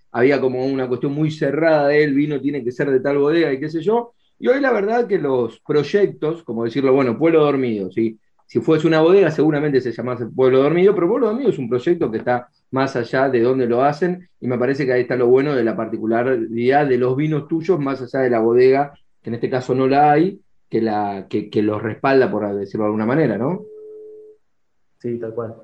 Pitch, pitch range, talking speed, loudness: 135 Hz, 120-155 Hz, 230 wpm, -18 LUFS